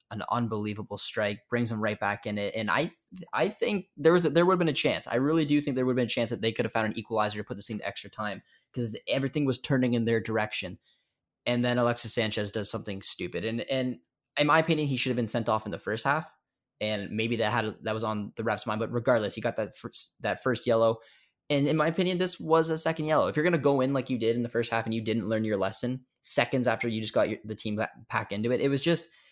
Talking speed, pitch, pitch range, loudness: 275 wpm, 120 Hz, 110-135 Hz, -28 LUFS